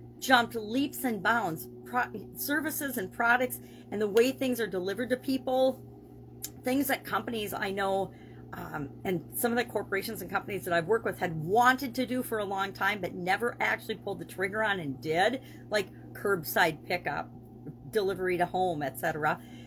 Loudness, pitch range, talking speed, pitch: -30 LUFS, 180-245 Hz, 175 wpm, 205 Hz